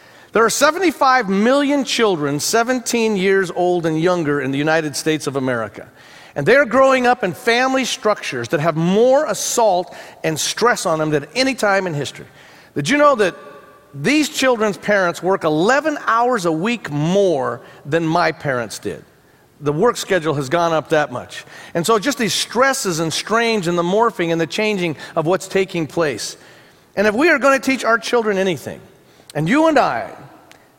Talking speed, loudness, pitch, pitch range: 180 wpm, -17 LUFS, 195 Hz, 160-240 Hz